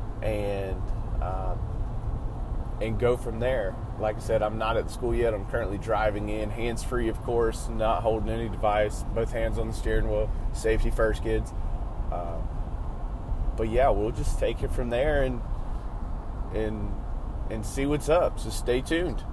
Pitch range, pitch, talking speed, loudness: 105-115 Hz, 110 Hz, 165 wpm, -29 LUFS